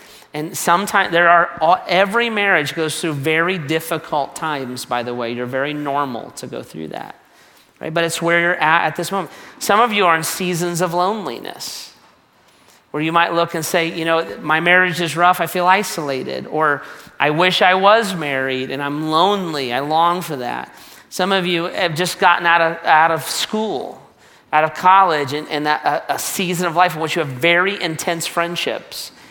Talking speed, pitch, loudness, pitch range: 195 wpm, 170 Hz, -17 LUFS, 155-180 Hz